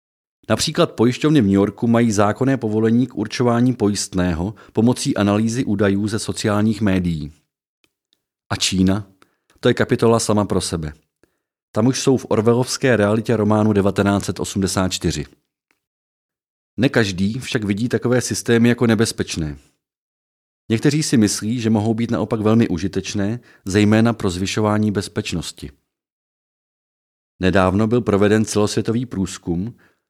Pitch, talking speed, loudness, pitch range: 105 Hz, 115 wpm, -18 LUFS, 95-115 Hz